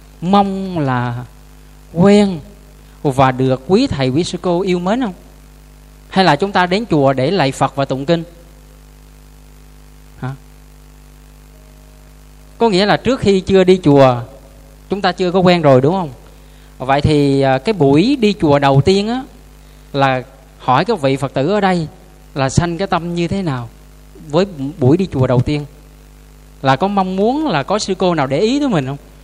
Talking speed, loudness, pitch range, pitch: 175 wpm, -15 LUFS, 135-190 Hz, 150 Hz